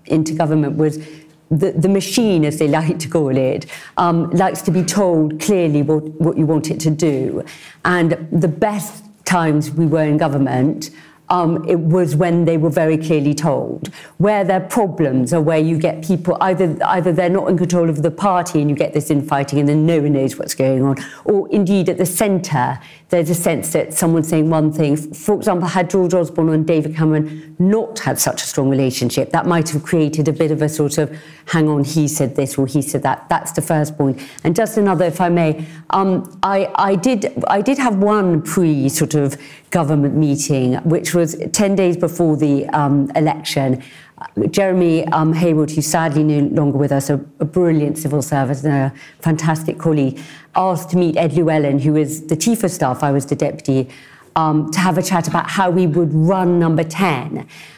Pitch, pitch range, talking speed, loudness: 160 Hz, 150-175 Hz, 200 wpm, -16 LUFS